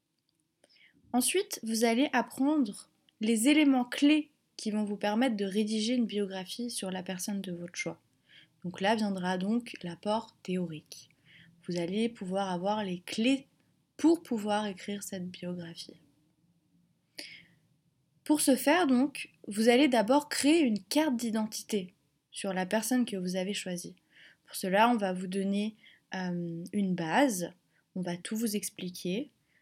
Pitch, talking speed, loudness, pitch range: 205 Hz, 140 wpm, -30 LUFS, 180-235 Hz